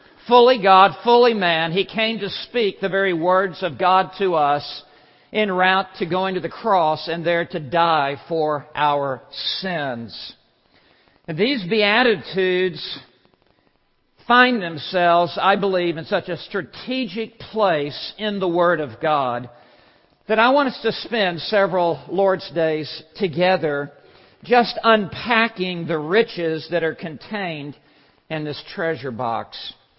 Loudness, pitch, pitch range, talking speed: -19 LUFS, 180 Hz, 155-205 Hz, 135 wpm